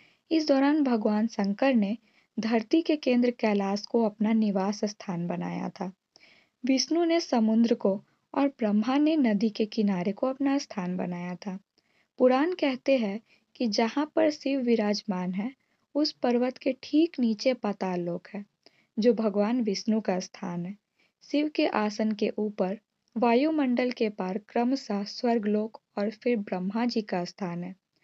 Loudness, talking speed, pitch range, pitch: -27 LUFS, 150 wpm, 205-260 Hz, 225 Hz